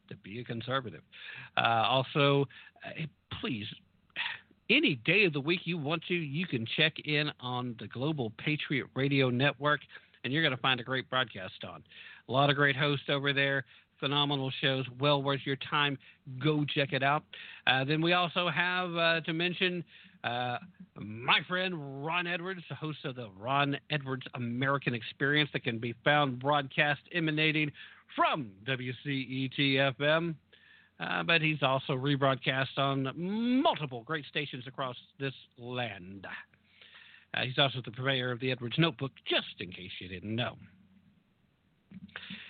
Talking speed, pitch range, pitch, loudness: 150 wpm, 130-155 Hz, 140 Hz, -31 LUFS